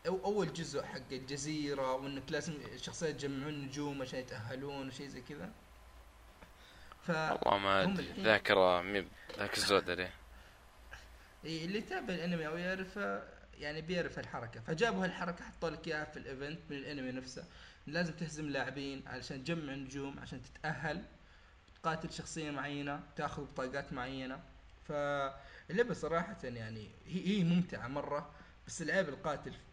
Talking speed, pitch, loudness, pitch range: 125 wpm, 145 Hz, -38 LUFS, 130-160 Hz